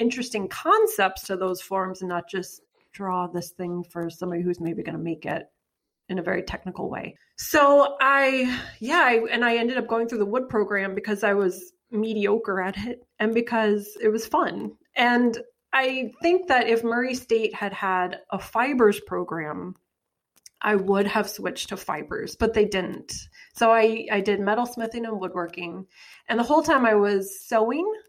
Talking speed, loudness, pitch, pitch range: 180 wpm, -24 LUFS, 215 Hz, 190-245 Hz